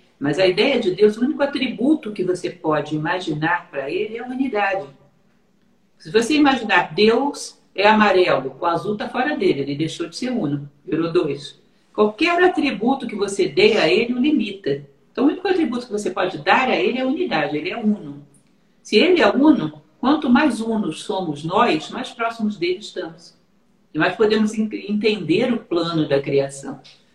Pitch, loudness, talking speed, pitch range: 210 Hz, -19 LUFS, 180 wpm, 170-245 Hz